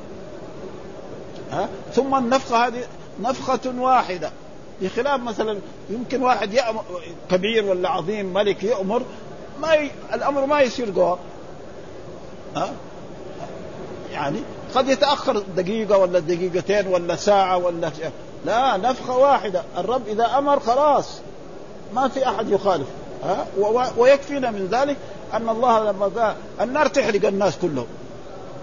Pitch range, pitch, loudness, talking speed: 190-260 Hz, 220 Hz, -21 LUFS, 125 wpm